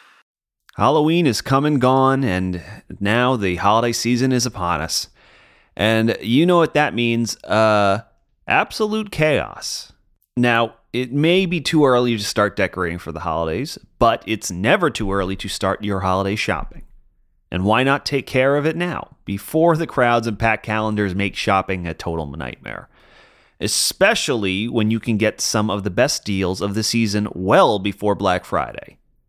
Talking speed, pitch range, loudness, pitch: 165 wpm, 95-130 Hz, -19 LUFS, 110 Hz